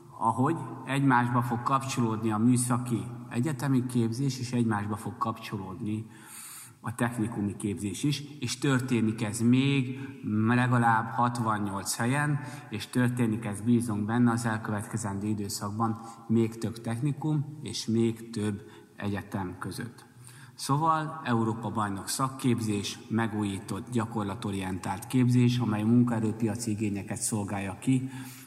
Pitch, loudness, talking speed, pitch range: 115 Hz, -29 LUFS, 110 wpm, 105-125 Hz